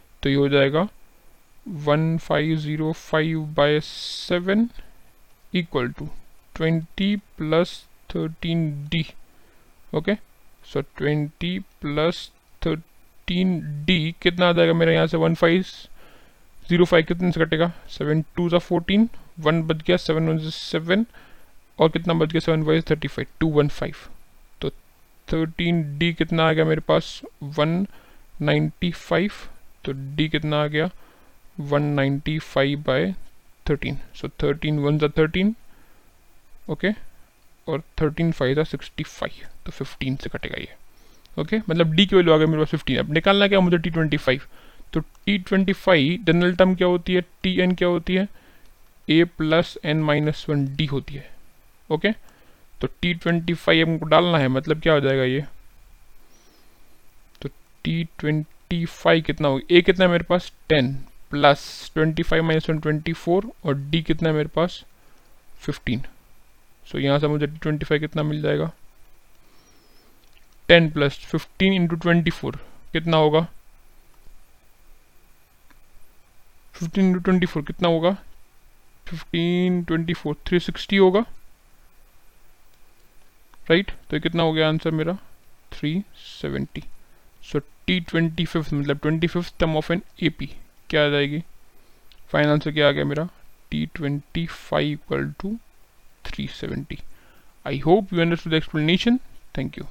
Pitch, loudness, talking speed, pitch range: 160 Hz, -22 LUFS, 140 wpm, 145-175 Hz